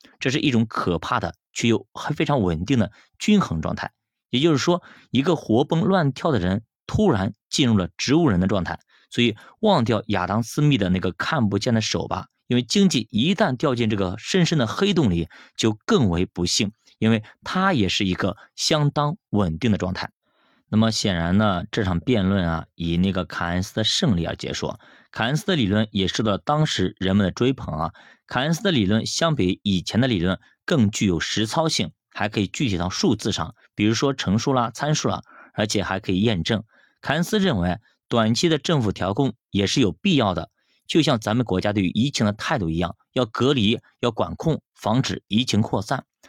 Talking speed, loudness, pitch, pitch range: 290 characters per minute, -22 LUFS, 110 Hz, 95-145 Hz